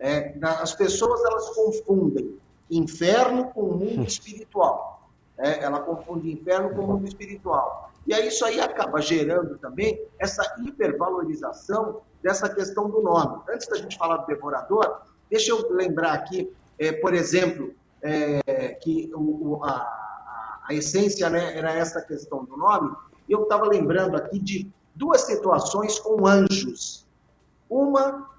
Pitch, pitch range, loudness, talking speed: 195 Hz, 165-225 Hz, -24 LUFS, 140 wpm